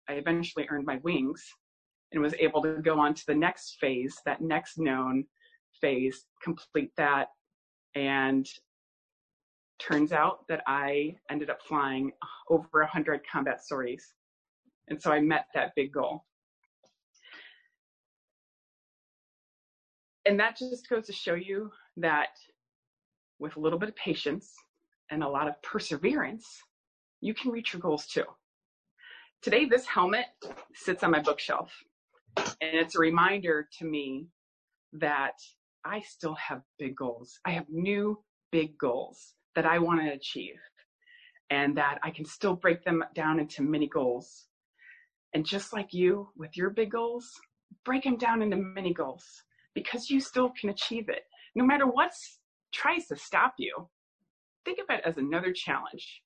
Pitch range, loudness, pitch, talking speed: 150-225 Hz, -30 LUFS, 165 Hz, 150 wpm